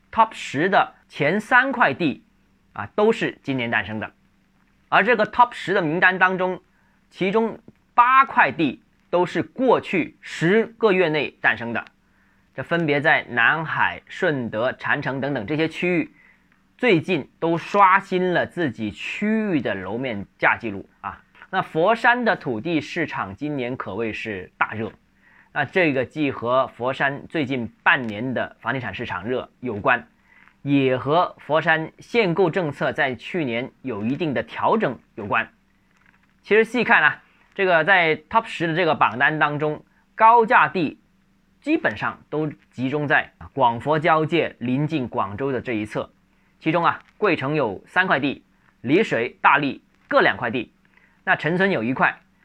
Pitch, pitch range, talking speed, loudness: 160 Hz, 130-200 Hz, 225 characters per minute, -21 LUFS